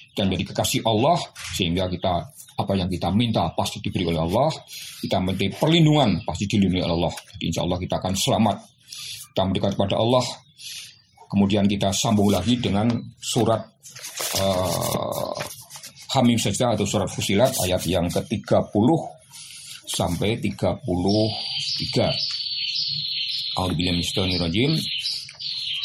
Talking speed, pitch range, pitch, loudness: 115 wpm, 95-120 Hz, 105 Hz, -23 LUFS